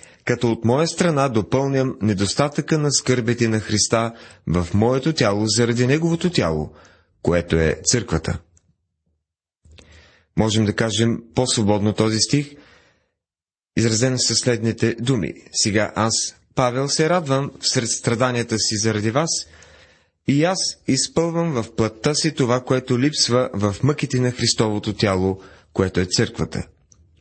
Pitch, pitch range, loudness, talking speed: 115 Hz, 95-130 Hz, -20 LUFS, 125 wpm